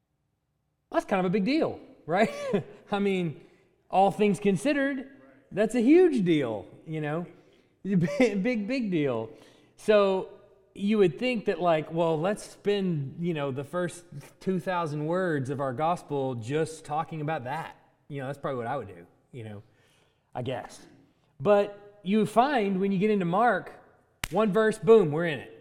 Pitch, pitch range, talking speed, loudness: 175 Hz, 150-205 Hz, 160 wpm, -27 LUFS